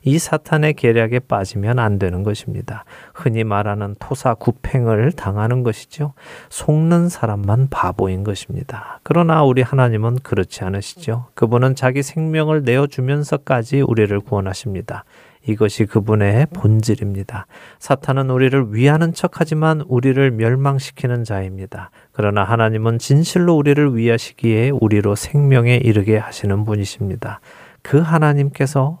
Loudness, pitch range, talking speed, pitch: -17 LUFS, 105-140 Hz, 335 characters per minute, 120 Hz